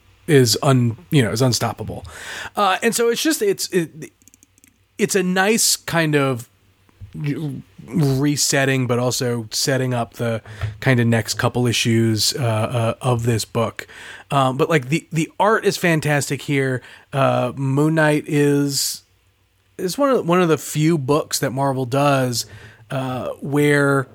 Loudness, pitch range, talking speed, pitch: -19 LUFS, 115-150 Hz, 150 wpm, 135 Hz